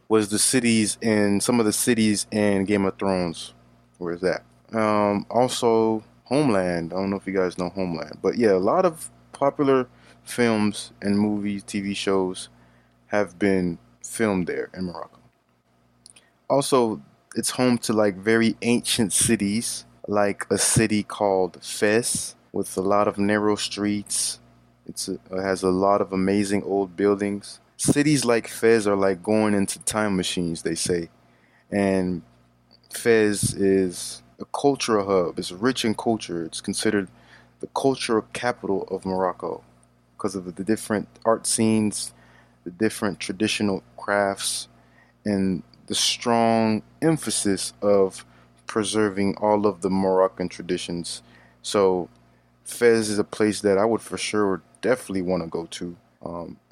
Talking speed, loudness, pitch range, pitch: 145 wpm, -23 LUFS, 90-110 Hz, 100 Hz